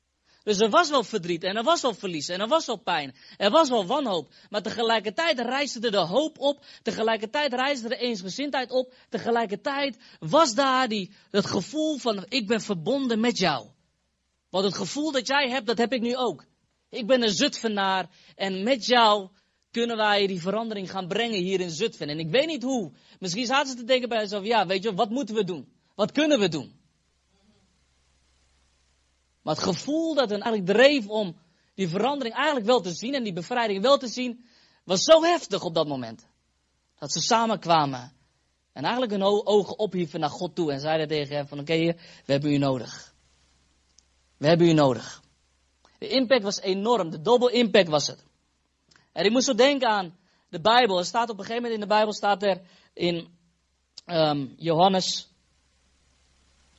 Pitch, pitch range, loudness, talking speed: 205 Hz, 155-245 Hz, -25 LUFS, 185 wpm